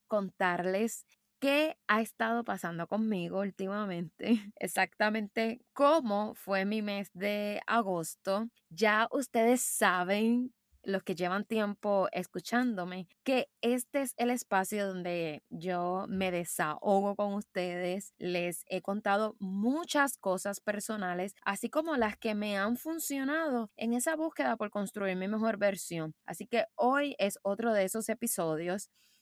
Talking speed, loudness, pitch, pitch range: 125 wpm, -32 LUFS, 205 Hz, 190-235 Hz